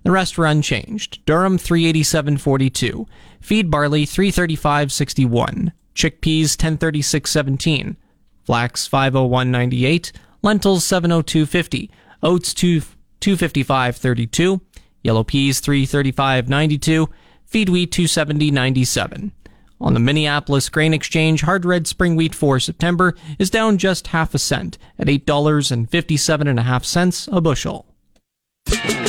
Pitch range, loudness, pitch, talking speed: 135-175 Hz, -17 LUFS, 155 Hz, 145 wpm